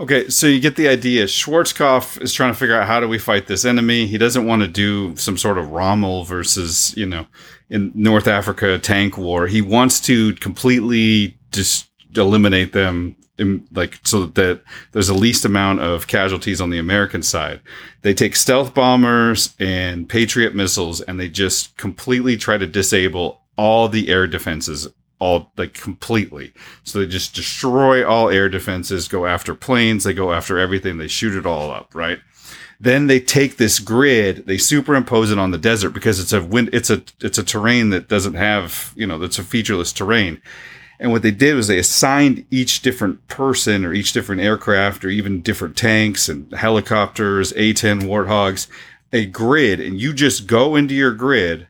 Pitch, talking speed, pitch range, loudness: 105 Hz, 185 wpm, 95-120 Hz, -16 LUFS